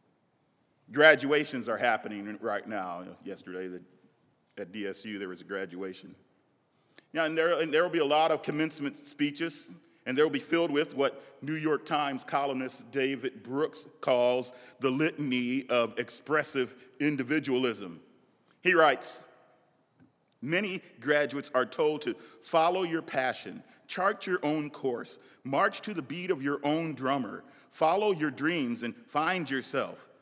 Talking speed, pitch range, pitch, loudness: 140 wpm, 125-155 Hz, 145 Hz, -30 LUFS